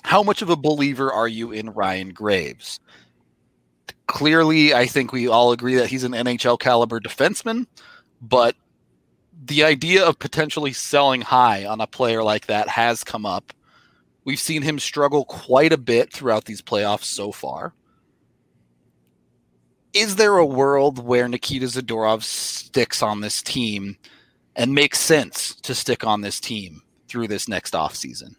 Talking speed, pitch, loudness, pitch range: 150 wpm, 125 Hz, -20 LUFS, 105-145 Hz